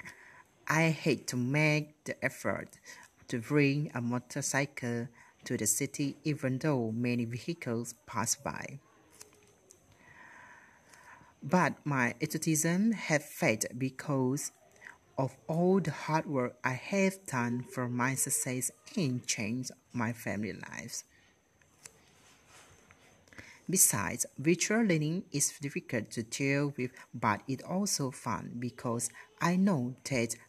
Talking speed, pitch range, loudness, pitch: 110 wpm, 120-155 Hz, -32 LUFS, 135 Hz